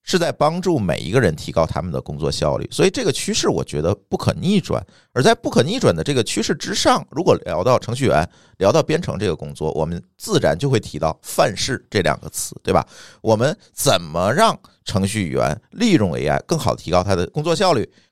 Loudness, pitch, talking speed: -19 LUFS, 95 Hz, 320 characters per minute